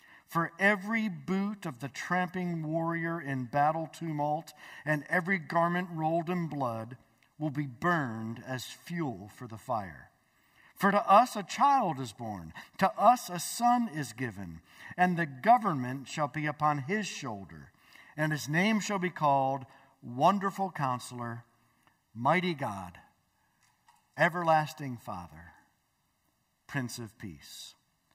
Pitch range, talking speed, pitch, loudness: 130-180 Hz, 130 wpm, 155 Hz, -30 LUFS